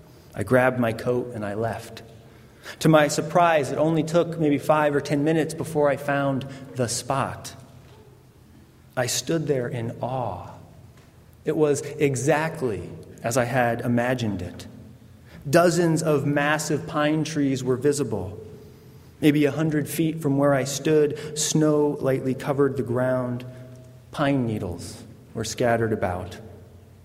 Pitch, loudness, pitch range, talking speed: 135 Hz, -23 LUFS, 115-150 Hz, 135 wpm